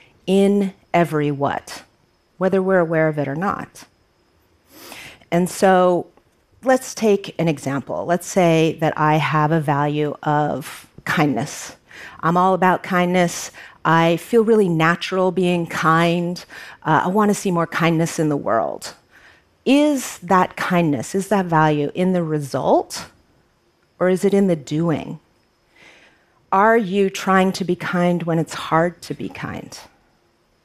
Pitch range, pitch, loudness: 160-190 Hz, 175 Hz, -19 LUFS